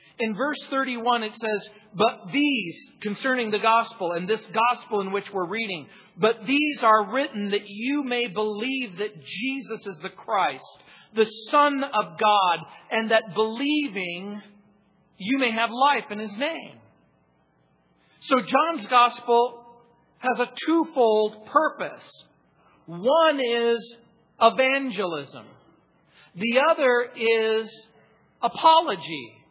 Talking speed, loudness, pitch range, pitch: 120 wpm, -24 LUFS, 210-260 Hz, 225 Hz